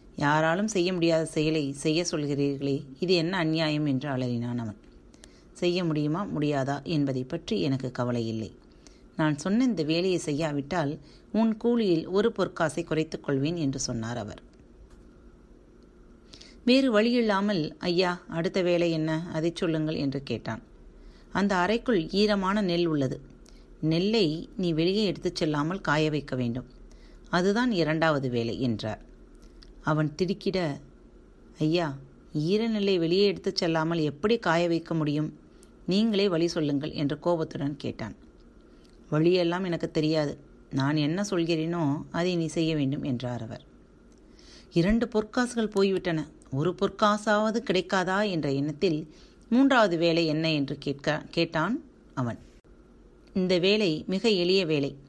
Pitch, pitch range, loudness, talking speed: 160 Hz, 140-185 Hz, -27 LUFS, 120 wpm